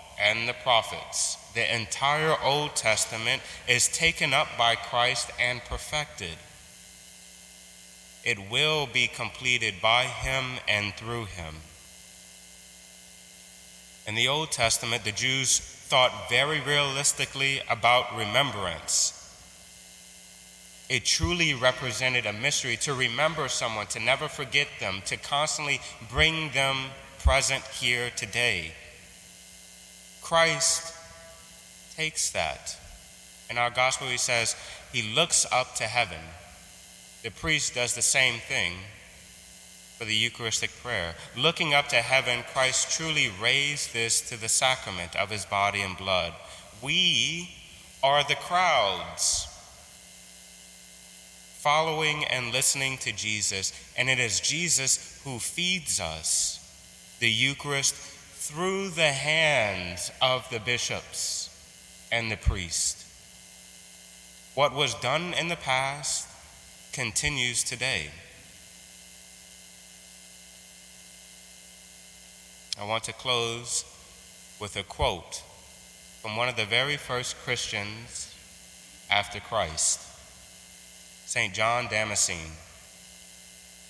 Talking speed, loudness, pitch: 105 wpm, -26 LUFS, 110 Hz